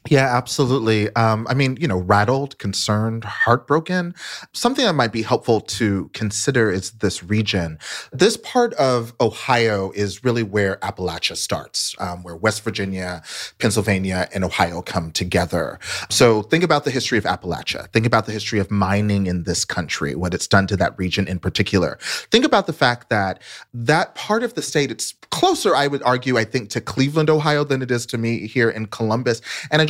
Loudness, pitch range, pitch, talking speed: -20 LUFS, 95-130 Hz, 110 Hz, 185 wpm